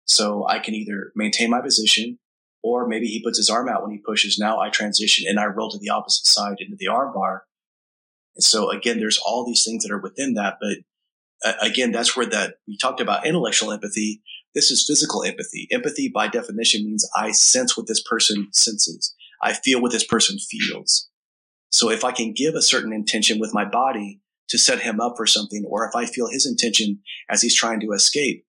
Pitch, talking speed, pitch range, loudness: 110 Hz, 210 wpm, 105-115 Hz, -19 LUFS